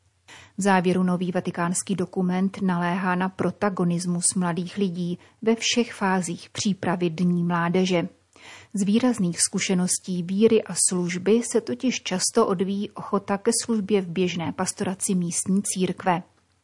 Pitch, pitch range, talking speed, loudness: 185 Hz, 175-200 Hz, 125 wpm, -24 LUFS